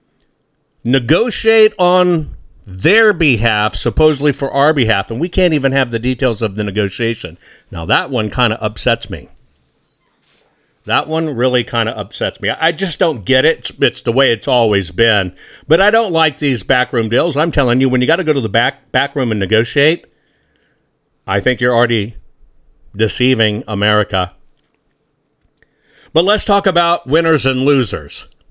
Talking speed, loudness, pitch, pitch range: 165 wpm, -14 LUFS, 130 Hz, 110-155 Hz